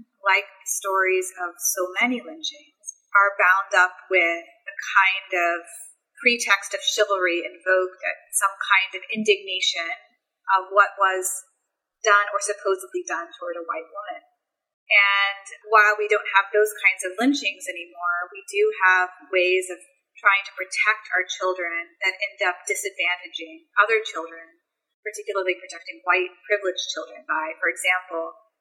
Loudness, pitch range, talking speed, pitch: -22 LUFS, 180-210 Hz, 145 wpm, 190 Hz